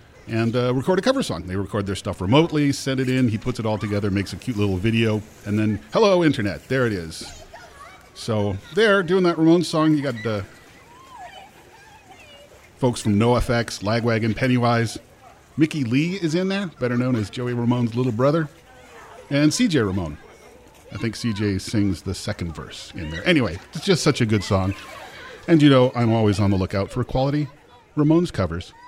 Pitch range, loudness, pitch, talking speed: 105-150 Hz, -21 LUFS, 120 Hz, 185 wpm